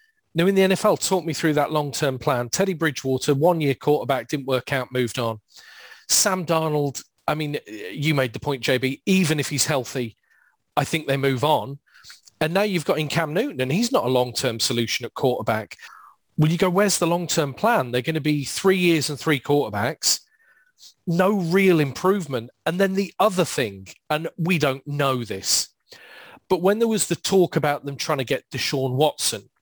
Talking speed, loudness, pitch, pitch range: 190 wpm, -22 LUFS, 150 Hz, 135-180 Hz